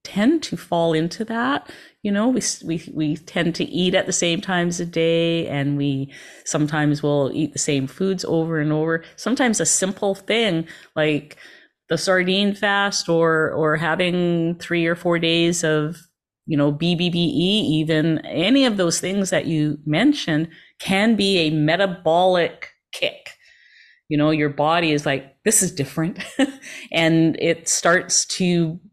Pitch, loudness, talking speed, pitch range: 165 Hz, -20 LUFS, 155 wpm, 155-190 Hz